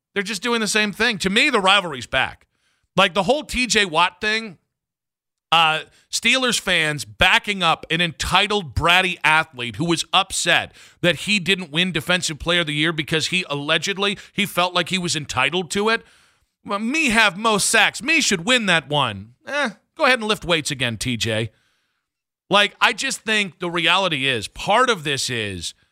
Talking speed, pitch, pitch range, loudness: 180 wpm, 180 Hz, 160-215 Hz, -19 LUFS